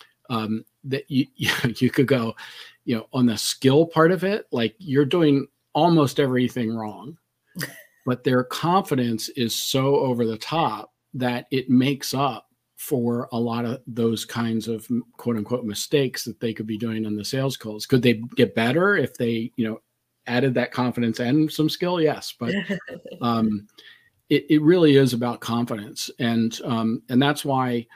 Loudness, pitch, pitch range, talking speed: -23 LUFS, 125 Hz, 115-140 Hz, 170 wpm